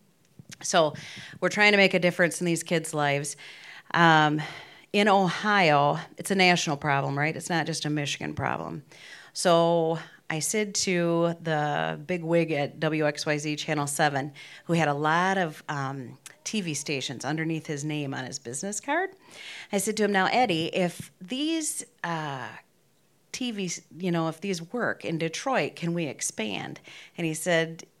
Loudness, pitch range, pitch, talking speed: -26 LUFS, 150-185 Hz, 165 Hz, 160 wpm